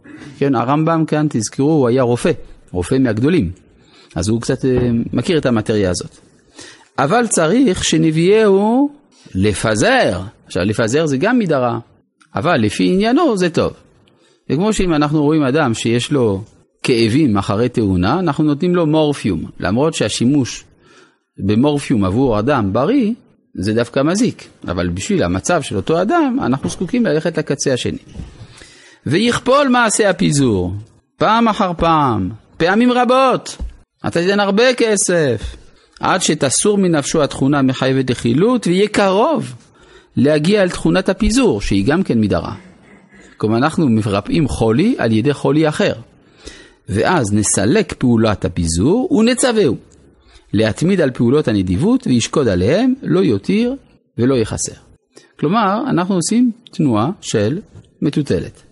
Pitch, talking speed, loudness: 145 Hz, 125 wpm, -15 LUFS